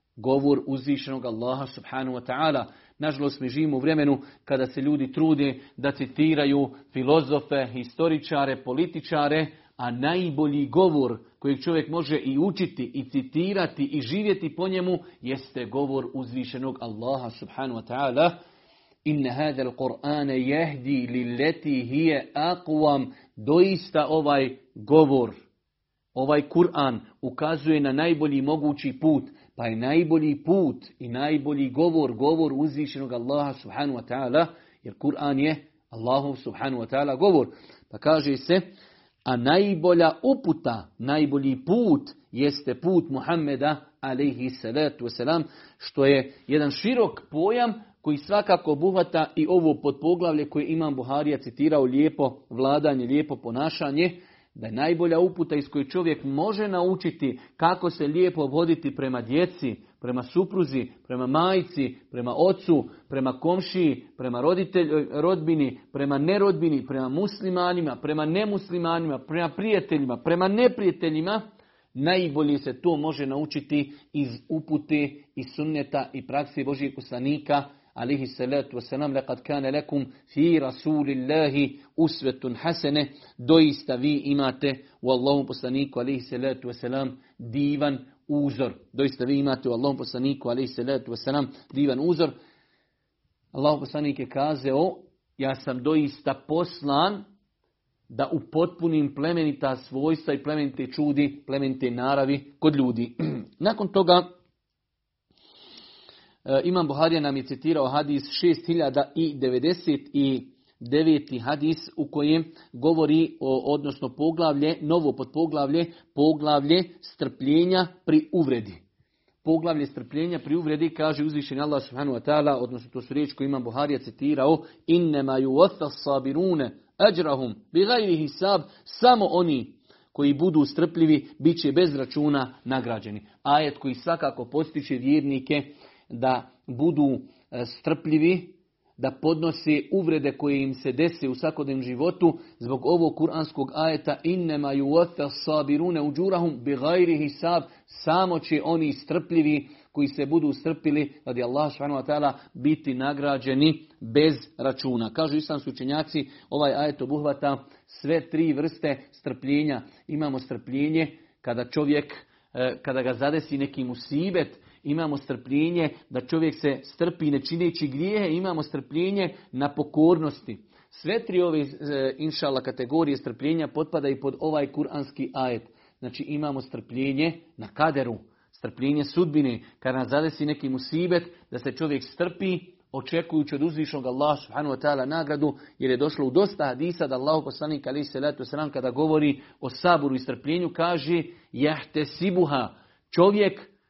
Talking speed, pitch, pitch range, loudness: 125 wpm, 145 Hz, 135-160 Hz, -25 LUFS